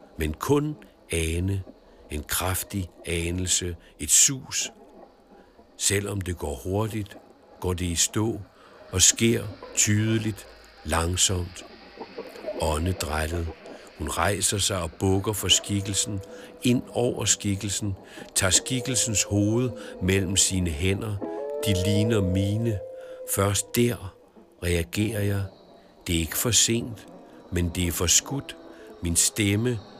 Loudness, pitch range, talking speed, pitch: -24 LUFS, 90-110 Hz, 110 wpm, 100 Hz